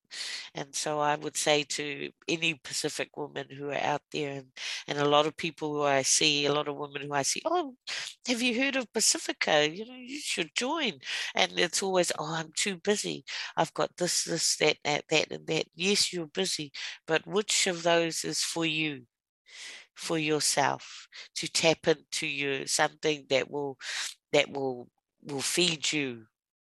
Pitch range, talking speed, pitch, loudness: 145-180 Hz, 180 wpm, 155 Hz, -29 LUFS